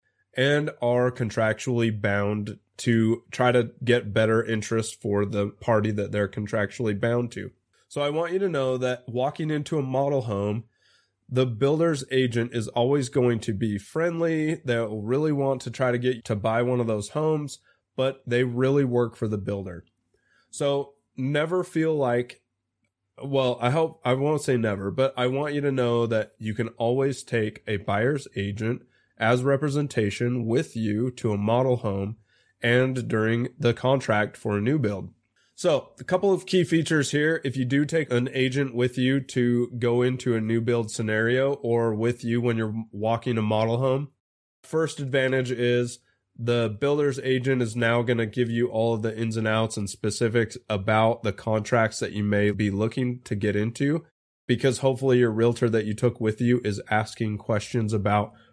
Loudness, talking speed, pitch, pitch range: -25 LUFS, 180 wpm, 120 Hz, 110-135 Hz